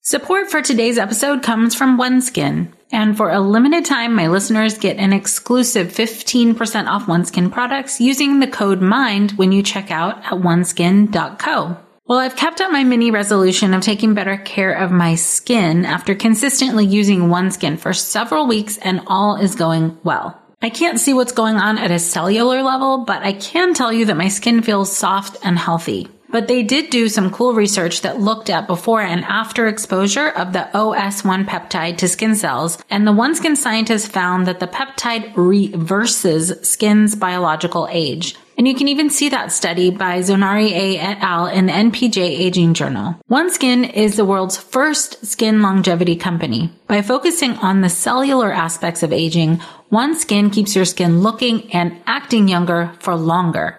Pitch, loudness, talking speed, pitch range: 205 Hz, -16 LUFS, 175 wpm, 180-235 Hz